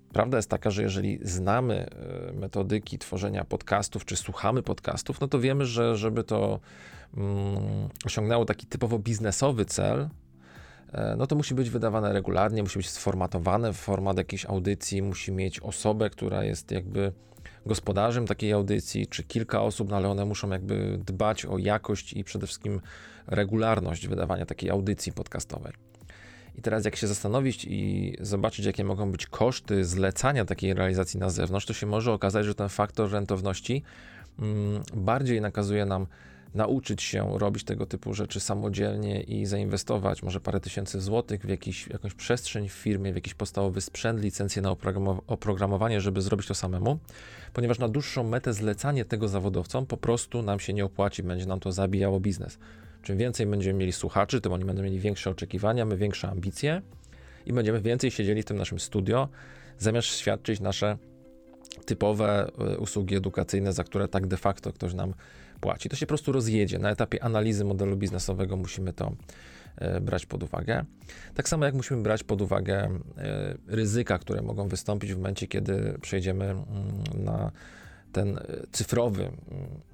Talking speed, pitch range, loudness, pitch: 160 wpm, 95-110 Hz, -29 LUFS, 100 Hz